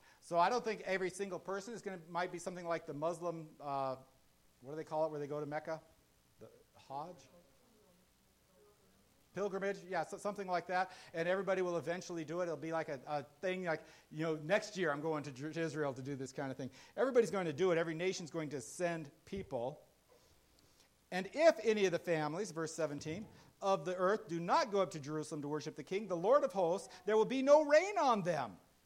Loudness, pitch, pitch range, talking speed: -37 LUFS, 170 Hz, 150-190 Hz, 225 wpm